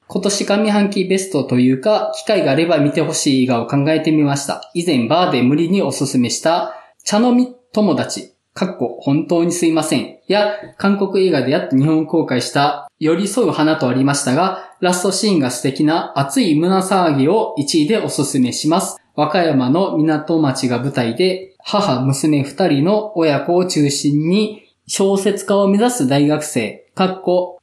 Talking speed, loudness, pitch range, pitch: 320 characters per minute, -16 LUFS, 140-195 Hz, 160 Hz